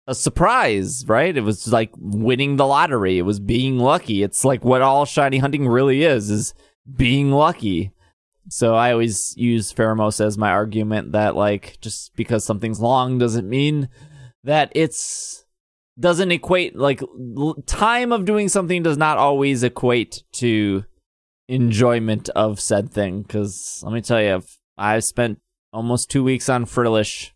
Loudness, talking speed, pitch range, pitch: -19 LUFS, 155 wpm, 105-140 Hz, 120 Hz